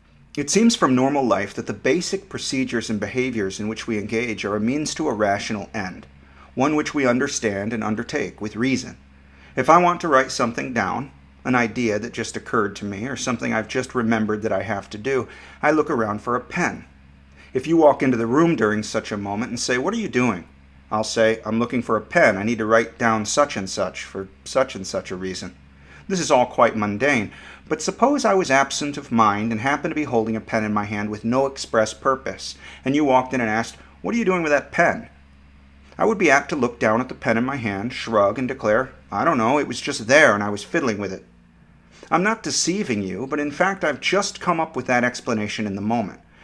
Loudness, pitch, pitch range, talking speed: -21 LUFS, 115 Hz, 100-135 Hz, 235 wpm